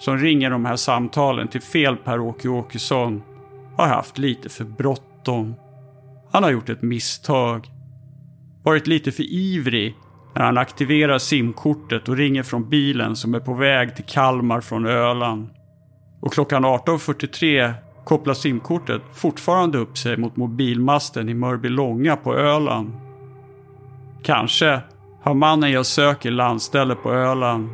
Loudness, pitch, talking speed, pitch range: -20 LUFS, 130 Hz, 130 wpm, 120-145 Hz